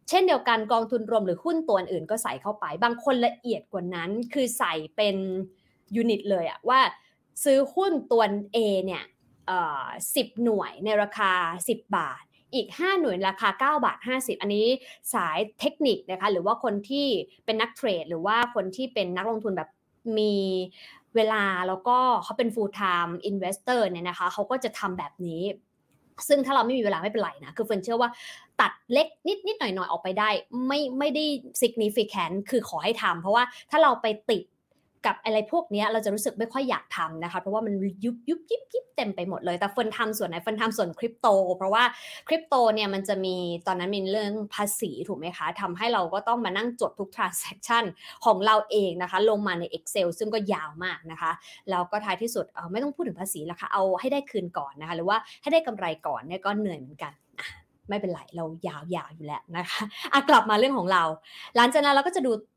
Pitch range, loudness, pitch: 185-240 Hz, -26 LUFS, 215 Hz